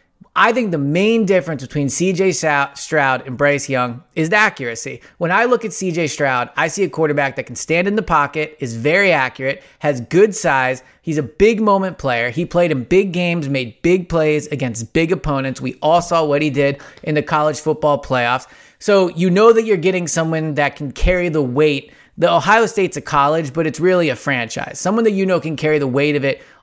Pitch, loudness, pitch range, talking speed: 155 Hz, -17 LUFS, 140-180 Hz, 215 wpm